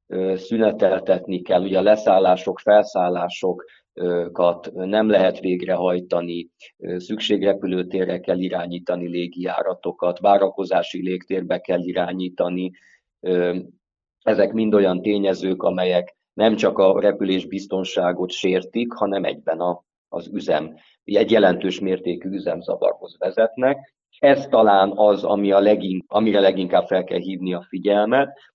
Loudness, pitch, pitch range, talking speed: -20 LUFS, 95 Hz, 90-100 Hz, 100 wpm